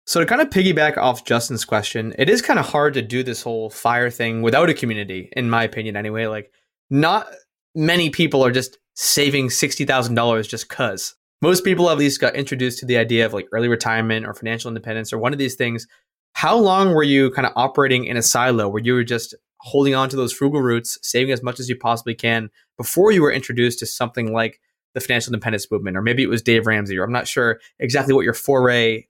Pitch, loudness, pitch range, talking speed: 120 Hz, -19 LUFS, 115-135 Hz, 225 wpm